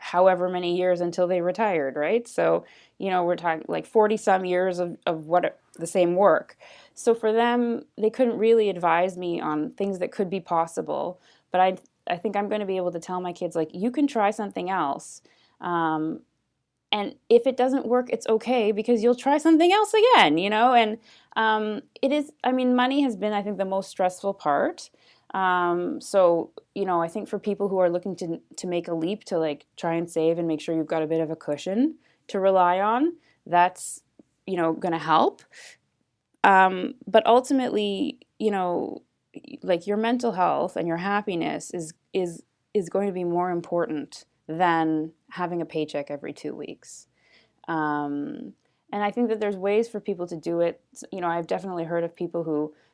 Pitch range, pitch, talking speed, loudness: 170-220 Hz, 185 Hz, 195 wpm, -24 LUFS